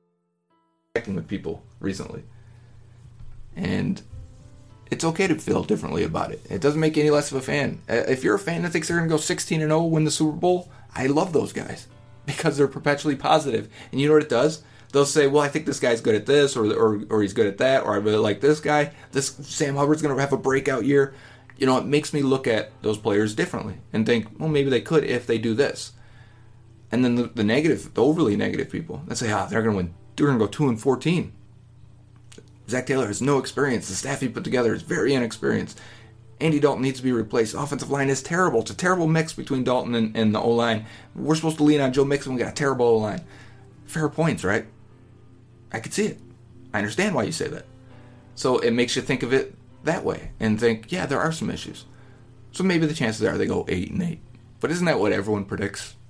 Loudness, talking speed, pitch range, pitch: -23 LUFS, 230 wpm, 115-145 Hz, 130 Hz